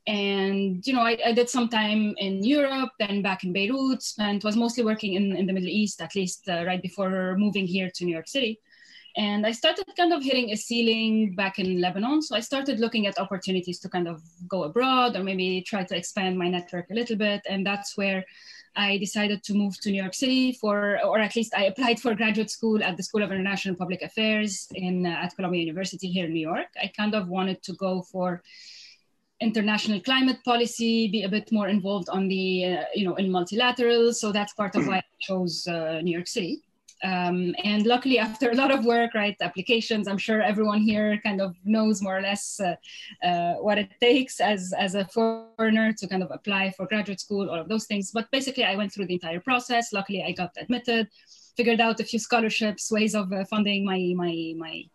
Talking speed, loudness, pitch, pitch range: 215 wpm, -25 LUFS, 205 Hz, 185-225 Hz